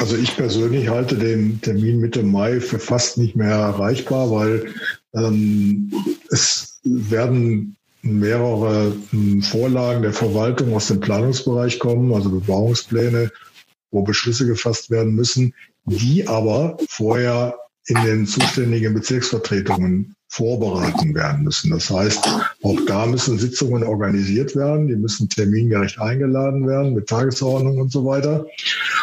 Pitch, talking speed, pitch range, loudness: 115 Hz, 125 wpm, 110-125 Hz, -19 LUFS